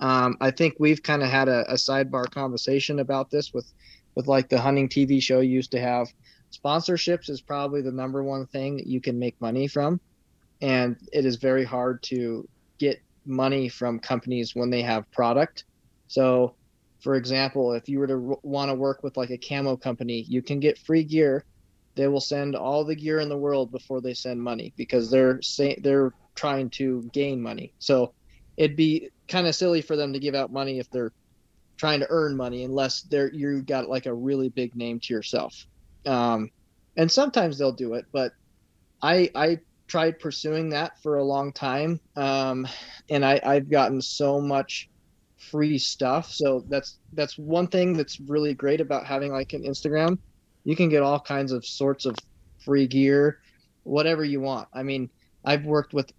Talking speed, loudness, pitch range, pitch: 190 wpm, -25 LUFS, 125-145 Hz, 135 Hz